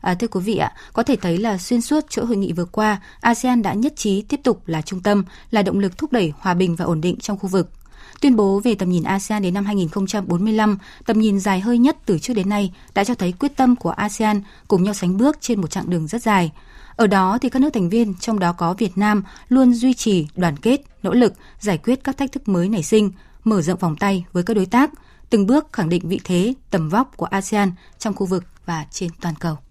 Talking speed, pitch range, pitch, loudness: 255 wpm, 185-235 Hz, 205 Hz, -19 LUFS